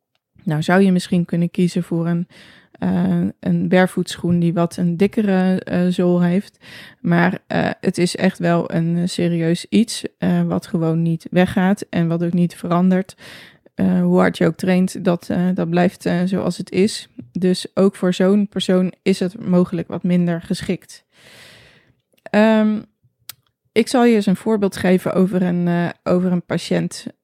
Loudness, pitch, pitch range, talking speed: -18 LUFS, 180 Hz, 175-190 Hz, 165 wpm